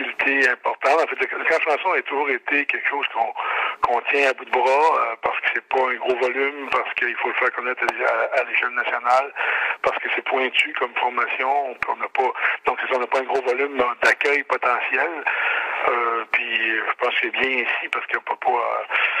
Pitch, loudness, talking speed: 140 Hz, -21 LUFS, 210 wpm